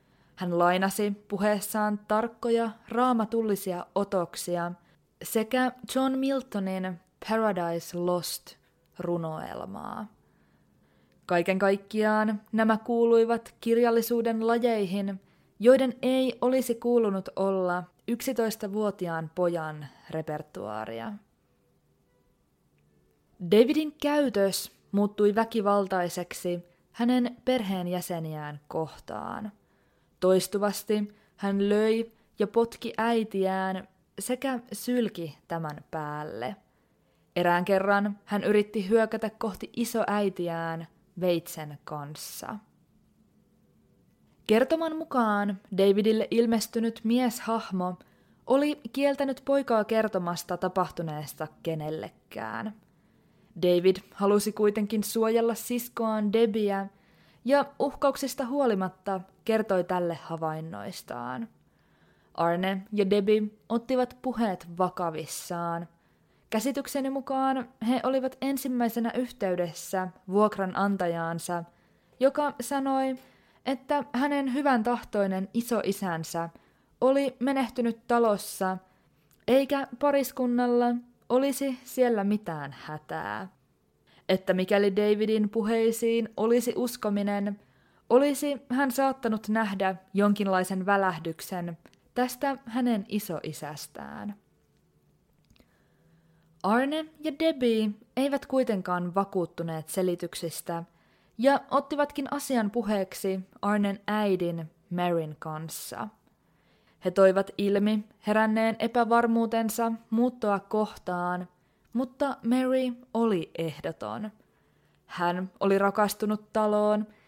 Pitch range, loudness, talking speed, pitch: 180-235 Hz, -28 LUFS, 75 wpm, 210 Hz